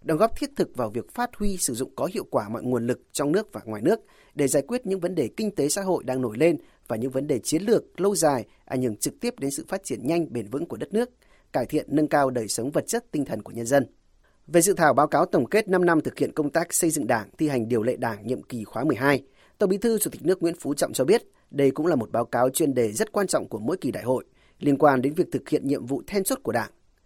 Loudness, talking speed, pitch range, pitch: -25 LUFS, 295 wpm, 130-185 Hz, 150 Hz